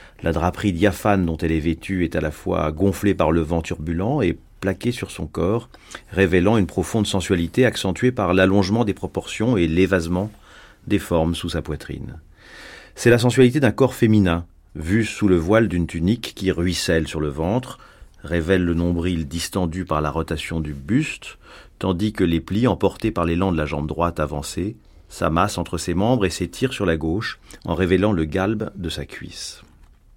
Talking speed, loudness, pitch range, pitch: 180 wpm, -21 LUFS, 80-105 Hz, 90 Hz